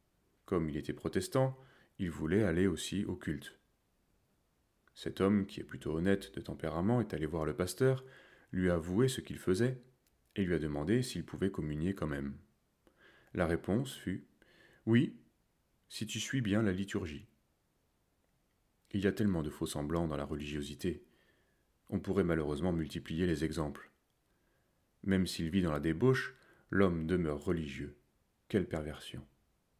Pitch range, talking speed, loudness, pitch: 75-100 Hz, 150 wpm, -35 LUFS, 90 Hz